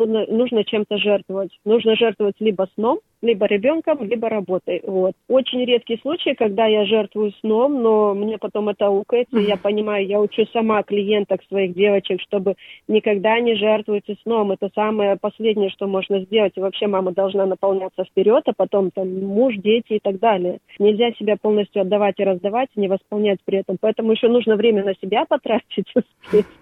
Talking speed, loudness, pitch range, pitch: 170 wpm, -19 LUFS, 195-225 Hz, 210 Hz